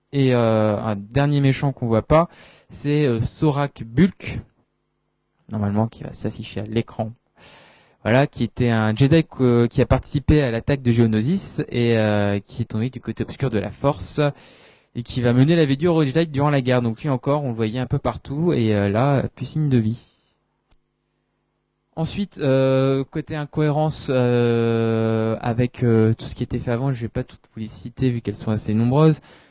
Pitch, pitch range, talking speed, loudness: 125 Hz, 110-145 Hz, 185 wpm, -21 LUFS